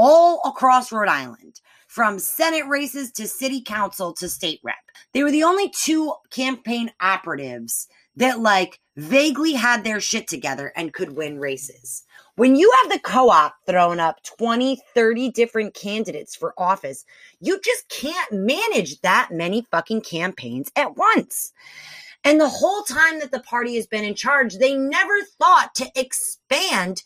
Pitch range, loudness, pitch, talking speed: 190-300 Hz, -20 LUFS, 240 Hz, 155 wpm